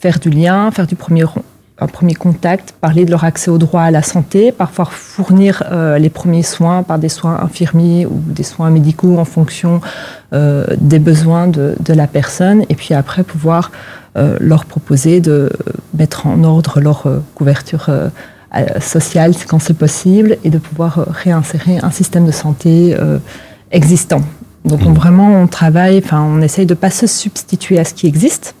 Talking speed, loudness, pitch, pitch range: 180 wpm, -11 LUFS, 165 Hz, 155-180 Hz